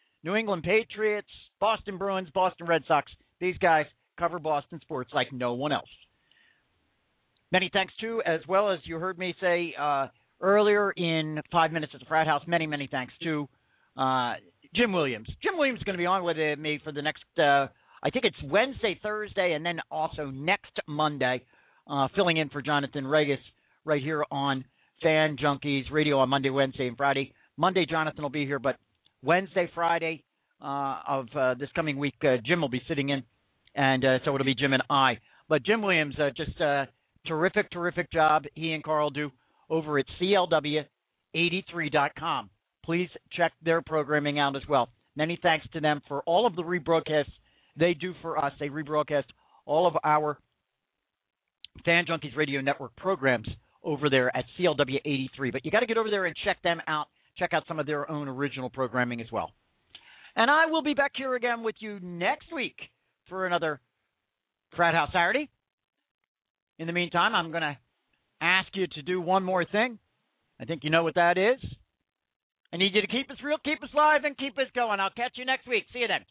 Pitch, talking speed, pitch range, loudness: 155 Hz, 190 wpm, 140-185 Hz, -27 LUFS